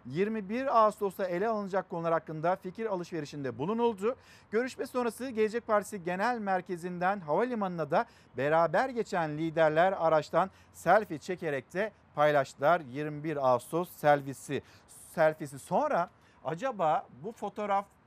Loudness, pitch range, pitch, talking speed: -31 LUFS, 155-210 Hz, 180 Hz, 110 wpm